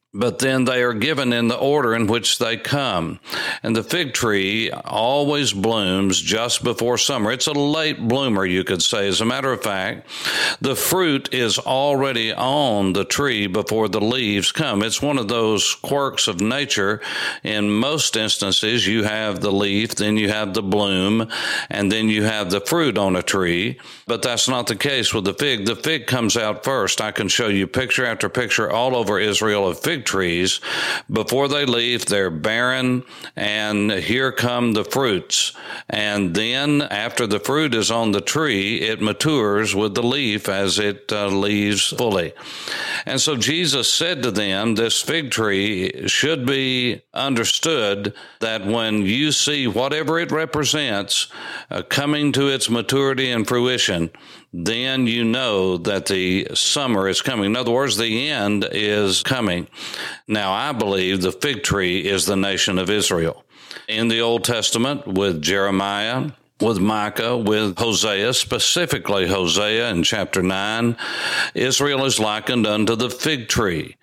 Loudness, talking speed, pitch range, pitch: -19 LUFS, 165 wpm, 100-125 Hz, 110 Hz